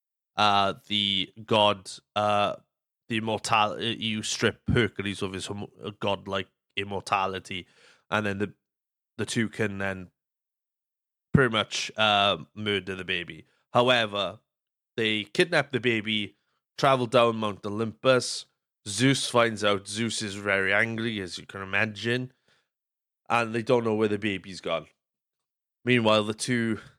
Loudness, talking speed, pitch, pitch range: -26 LUFS, 130 wpm, 105 Hz, 100-115 Hz